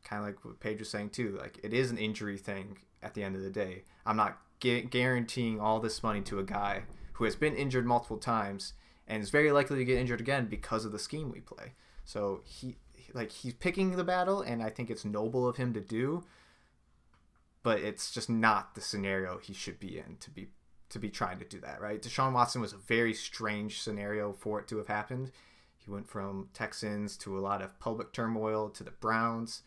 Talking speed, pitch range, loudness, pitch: 225 wpm, 100-120 Hz, -34 LUFS, 110 Hz